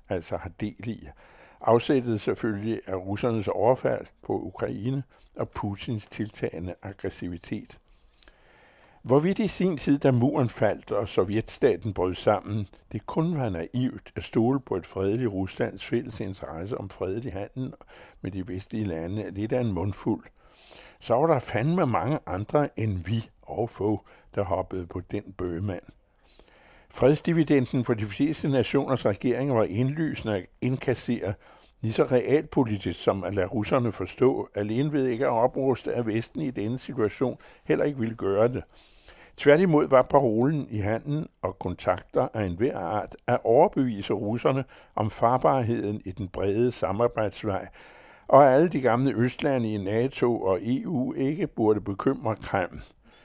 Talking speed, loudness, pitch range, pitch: 145 wpm, -27 LUFS, 100-130 Hz, 115 Hz